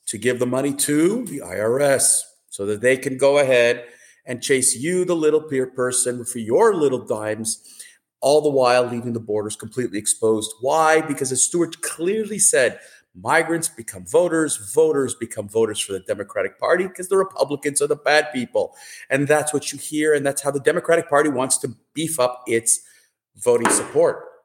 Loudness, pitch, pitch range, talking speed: -20 LUFS, 140 Hz, 120-160 Hz, 180 wpm